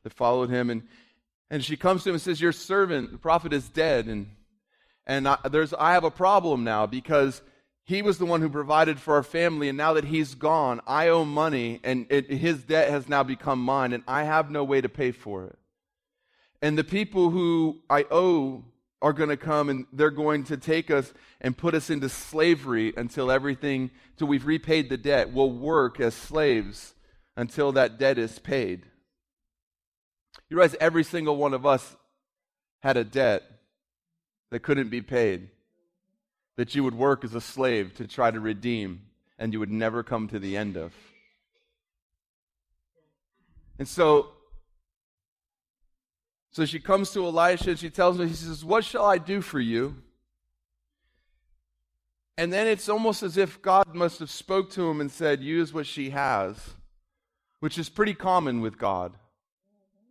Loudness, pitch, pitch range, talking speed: -25 LUFS, 145 Hz, 120-170 Hz, 175 wpm